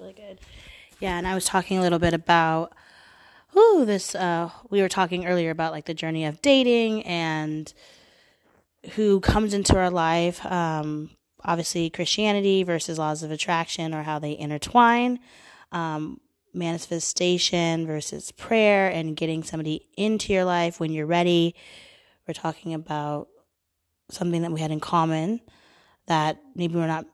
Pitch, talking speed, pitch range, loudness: 170 Hz, 150 wpm, 160-190 Hz, -24 LUFS